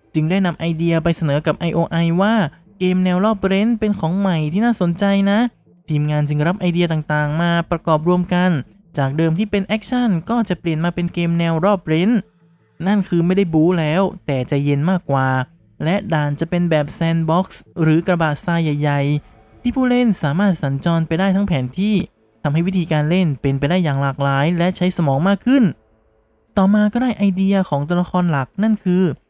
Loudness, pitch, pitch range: -18 LUFS, 170 Hz, 155-195 Hz